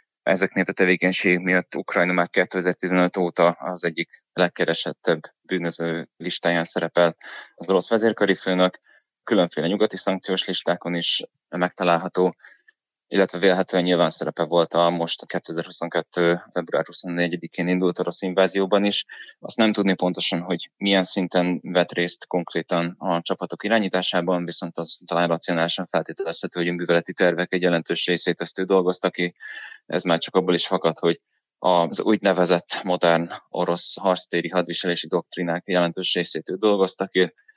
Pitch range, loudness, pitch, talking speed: 85-95 Hz, -22 LUFS, 90 Hz, 140 wpm